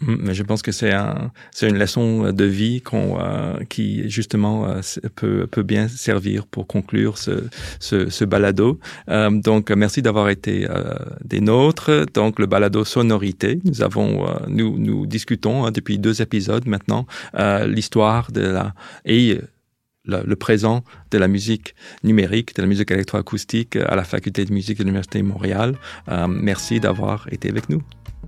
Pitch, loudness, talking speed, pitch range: 105 Hz, -20 LUFS, 170 wpm, 100-115 Hz